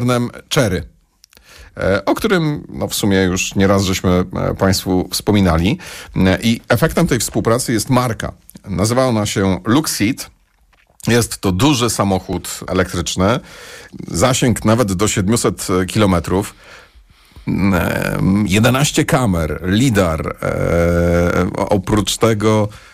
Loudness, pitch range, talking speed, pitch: -16 LUFS, 95-120 Hz, 90 wpm, 100 Hz